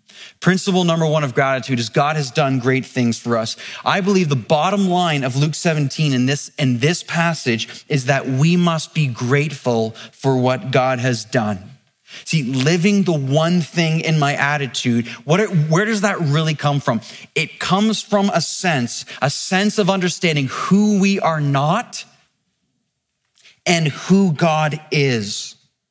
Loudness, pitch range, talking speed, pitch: -18 LUFS, 130-175 Hz, 160 wpm, 150 Hz